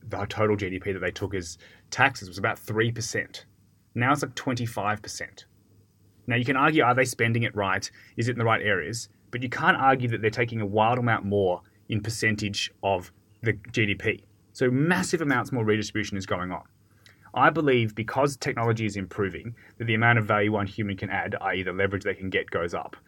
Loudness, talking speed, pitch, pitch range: -26 LUFS, 200 wpm, 110 Hz, 100-120 Hz